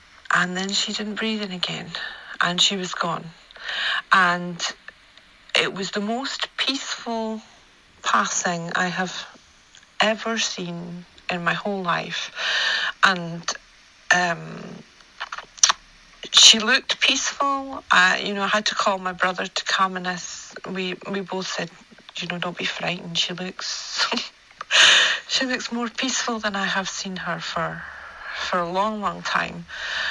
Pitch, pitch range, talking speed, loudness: 195 Hz, 180-220 Hz, 140 wpm, -21 LUFS